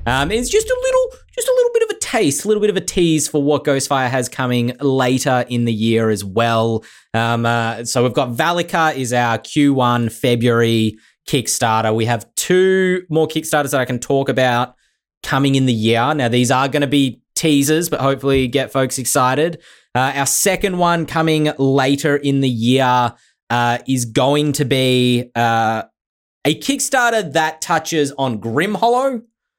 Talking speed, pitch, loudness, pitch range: 180 wpm, 135 Hz, -16 LUFS, 120-160 Hz